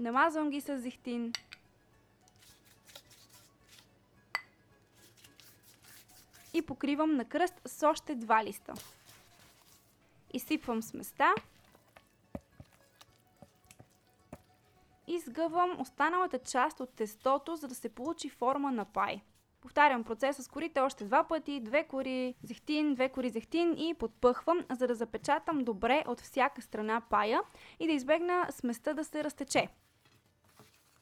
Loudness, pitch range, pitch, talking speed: -33 LUFS, 225-300 Hz, 260 Hz, 110 wpm